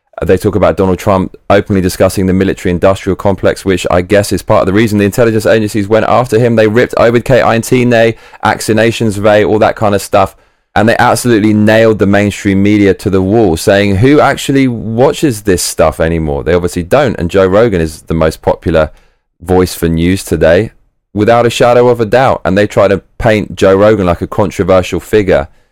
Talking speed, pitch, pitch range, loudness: 190 wpm, 100 Hz, 95-115 Hz, -9 LUFS